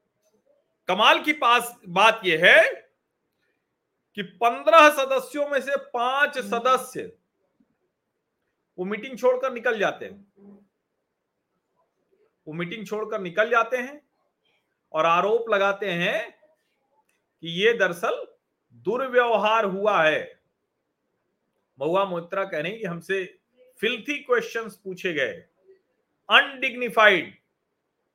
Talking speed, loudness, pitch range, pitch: 100 wpm, -22 LUFS, 200-275 Hz, 235 Hz